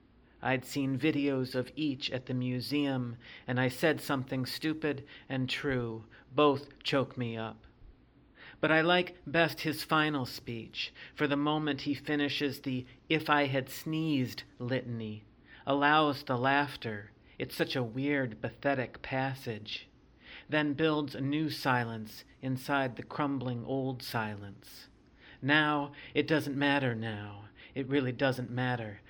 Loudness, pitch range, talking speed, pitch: -32 LUFS, 125-145 Hz, 135 wpm, 135 Hz